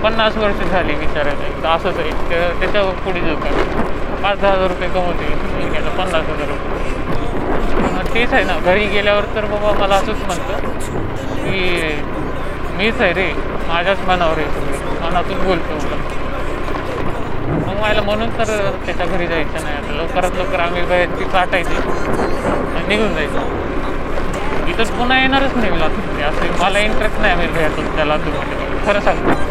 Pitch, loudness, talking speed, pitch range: 185 Hz, -18 LUFS, 150 wpm, 170-205 Hz